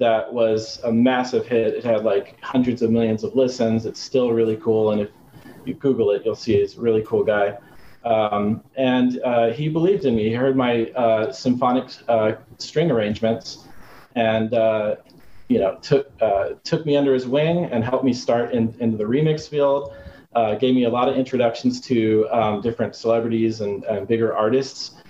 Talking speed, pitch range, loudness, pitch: 190 wpm, 110-130 Hz, -21 LUFS, 120 Hz